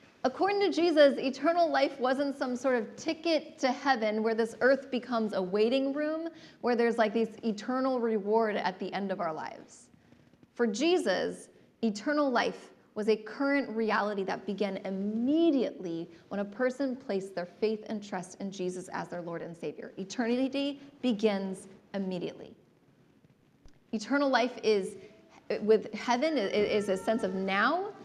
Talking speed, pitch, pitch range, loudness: 150 wpm, 230 Hz, 205-270 Hz, -30 LUFS